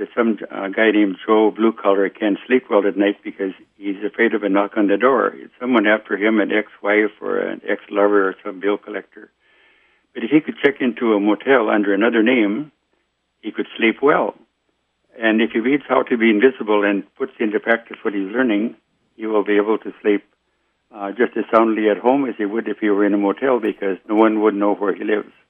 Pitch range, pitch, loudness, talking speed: 100-115 Hz, 105 Hz, -18 LUFS, 225 wpm